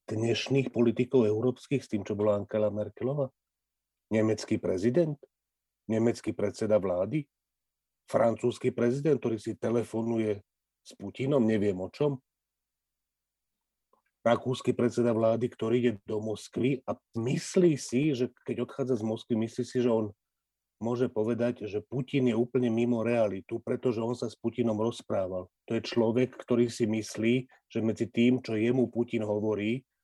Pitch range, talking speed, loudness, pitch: 110-125 Hz, 140 wpm, -30 LUFS, 115 Hz